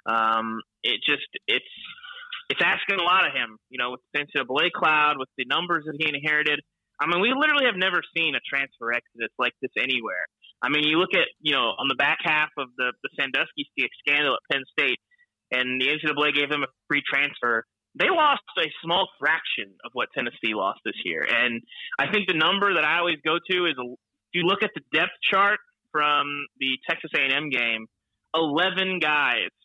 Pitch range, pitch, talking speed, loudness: 130-170 Hz, 150 Hz, 200 wpm, -23 LUFS